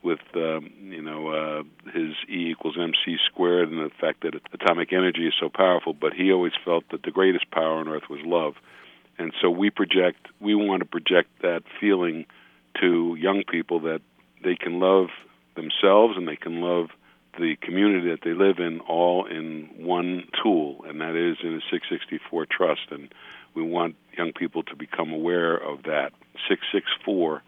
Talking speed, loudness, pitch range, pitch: 180 wpm, -24 LUFS, 80-90 Hz, 85 Hz